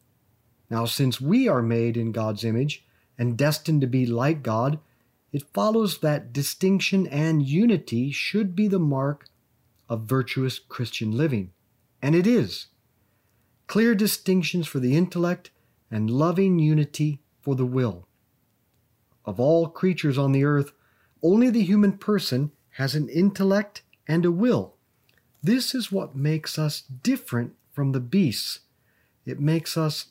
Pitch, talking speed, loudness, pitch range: 140 Hz, 140 wpm, -24 LUFS, 120-170 Hz